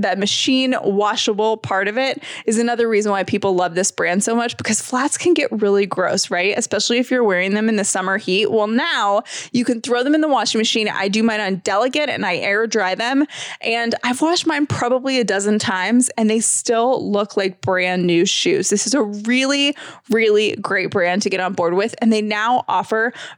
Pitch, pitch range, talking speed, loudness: 220 Hz, 200-245 Hz, 215 wpm, -18 LUFS